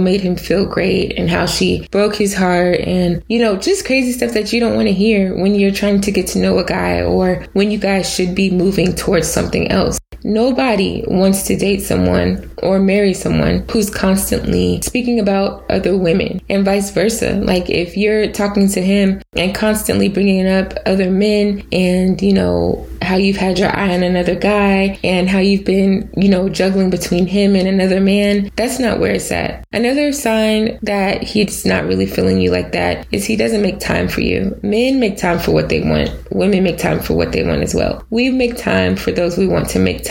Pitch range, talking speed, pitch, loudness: 180-210 Hz, 210 wpm, 195 Hz, -15 LUFS